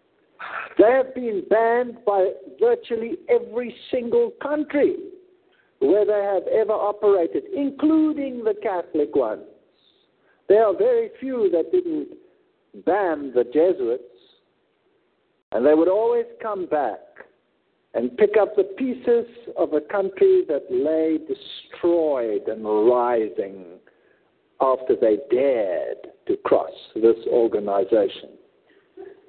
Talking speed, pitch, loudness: 110 wpm, 345 Hz, -22 LUFS